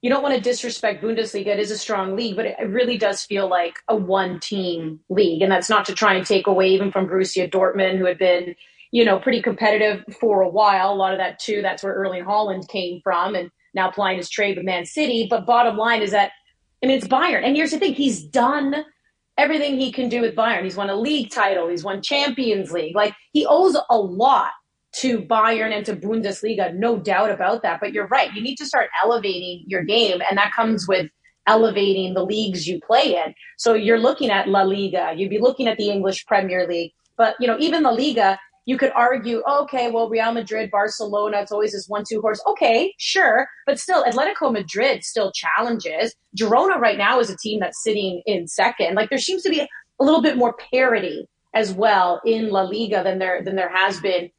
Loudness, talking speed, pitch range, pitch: -20 LUFS, 220 wpm, 190-240 Hz, 210 Hz